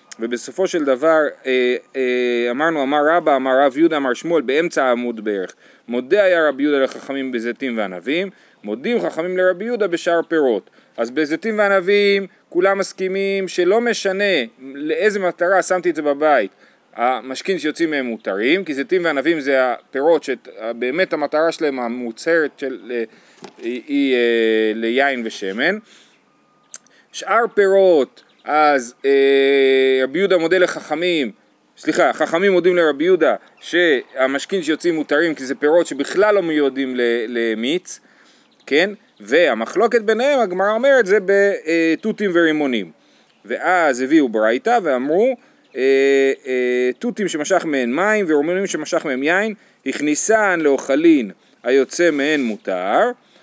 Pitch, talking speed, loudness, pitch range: 155 Hz, 125 wpm, -18 LUFS, 130-190 Hz